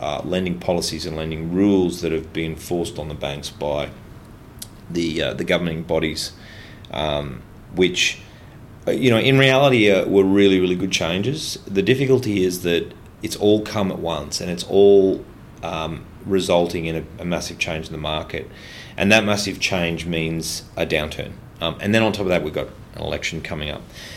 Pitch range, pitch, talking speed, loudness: 80-100 Hz, 90 Hz, 180 wpm, -20 LUFS